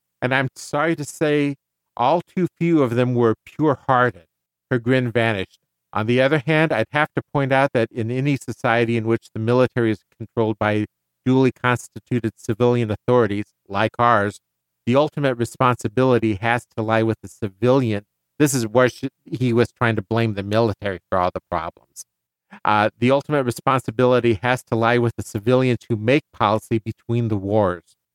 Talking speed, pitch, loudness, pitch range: 175 wpm, 120 Hz, -20 LUFS, 110-130 Hz